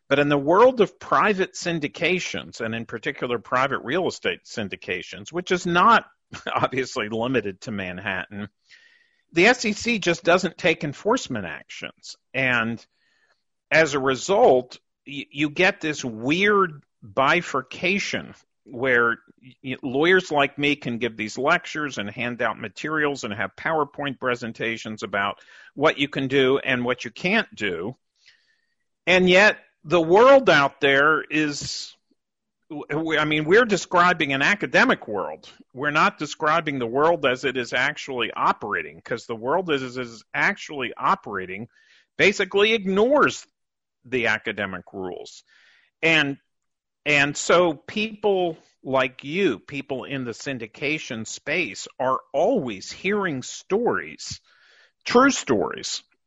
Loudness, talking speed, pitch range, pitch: -22 LUFS, 125 wpm, 125-180 Hz, 145 Hz